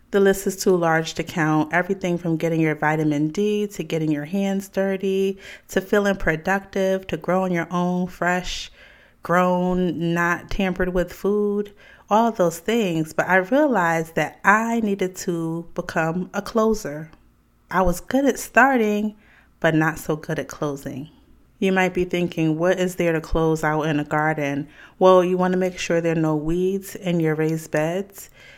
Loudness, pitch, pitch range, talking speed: -22 LUFS, 180 Hz, 160-195 Hz, 170 wpm